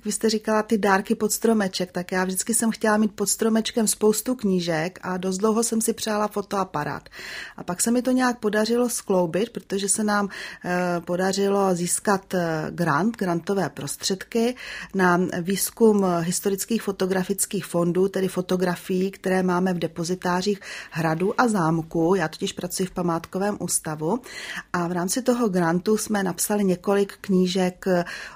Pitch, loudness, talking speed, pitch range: 195 Hz, -23 LUFS, 145 wpm, 180-215 Hz